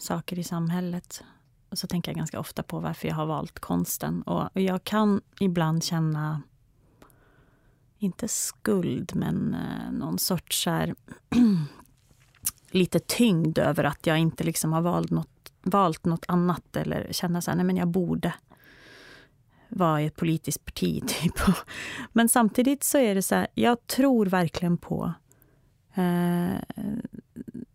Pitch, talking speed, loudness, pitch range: 175 Hz, 140 wpm, -26 LUFS, 140-195 Hz